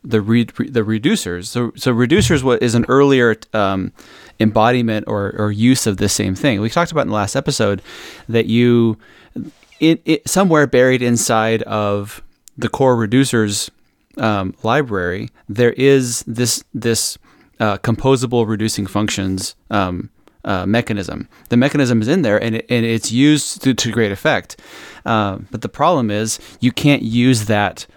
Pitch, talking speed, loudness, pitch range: 115 Hz, 160 wpm, -16 LUFS, 105-125 Hz